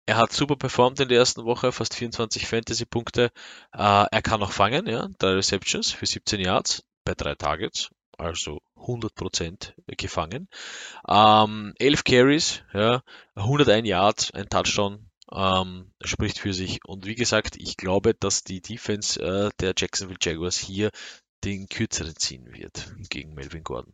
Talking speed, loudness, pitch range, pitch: 150 wpm, -24 LUFS, 95-115 Hz, 105 Hz